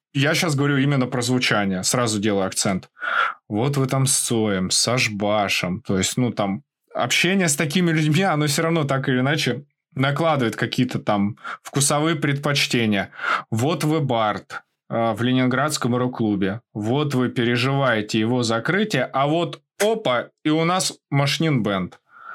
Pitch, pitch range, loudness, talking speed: 130 Hz, 115-150 Hz, -21 LUFS, 150 wpm